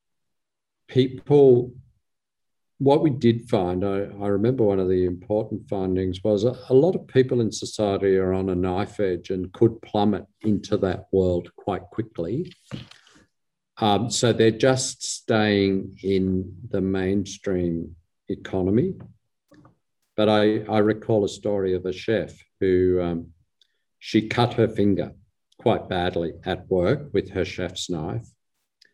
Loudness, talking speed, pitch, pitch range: -23 LUFS, 135 wpm, 100 Hz, 95-115 Hz